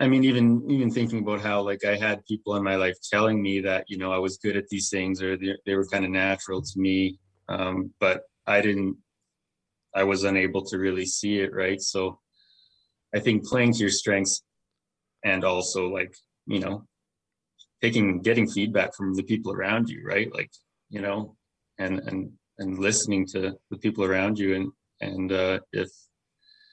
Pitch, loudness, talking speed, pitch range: 100 Hz, -26 LUFS, 185 wpm, 95-105 Hz